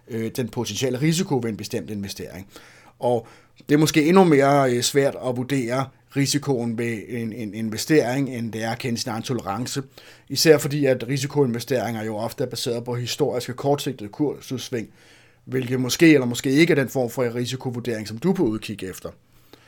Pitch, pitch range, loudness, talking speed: 125 Hz, 115-140 Hz, -22 LUFS, 170 wpm